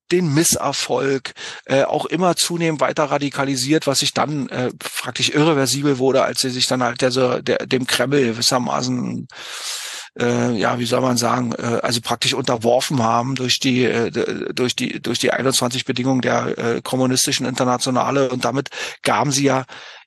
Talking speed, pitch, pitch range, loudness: 160 wpm, 130 Hz, 125-140 Hz, -19 LUFS